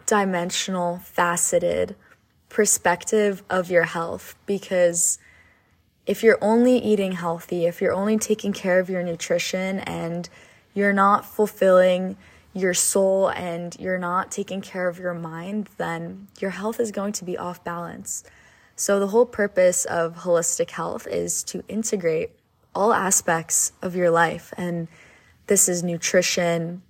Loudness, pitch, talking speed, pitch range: -22 LUFS, 185 Hz, 140 wpm, 170-200 Hz